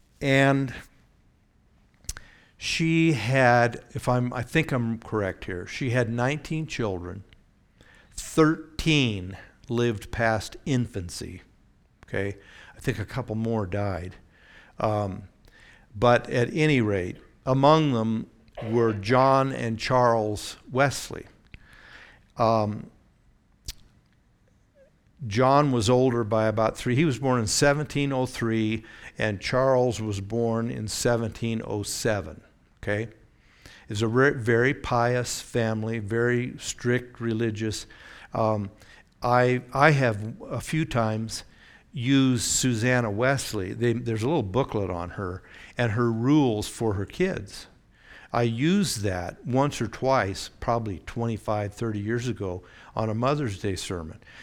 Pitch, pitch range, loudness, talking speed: 115 Hz, 105-125 Hz, -25 LUFS, 115 wpm